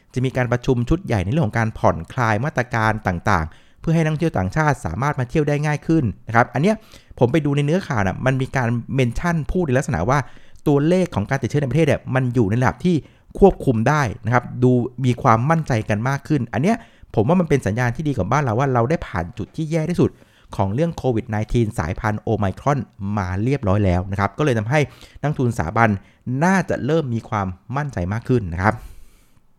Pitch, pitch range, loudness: 125 Hz, 110-150 Hz, -20 LUFS